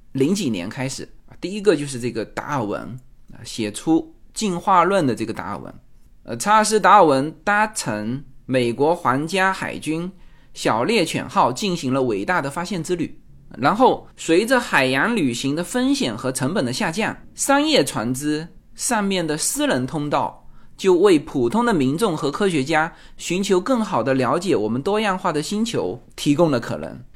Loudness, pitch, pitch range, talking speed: -20 LUFS, 165 Hz, 130-205 Hz, 255 characters per minute